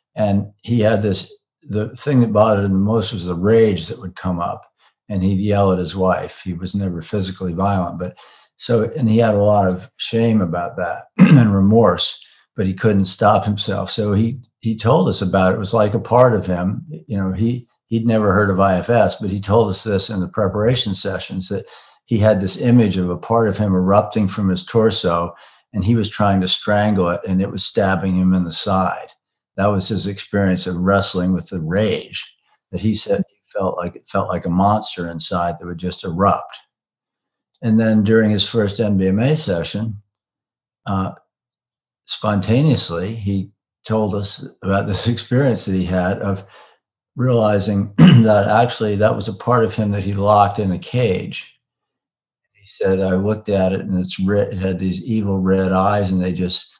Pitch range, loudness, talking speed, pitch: 95-110 Hz, -18 LUFS, 195 wpm, 100 Hz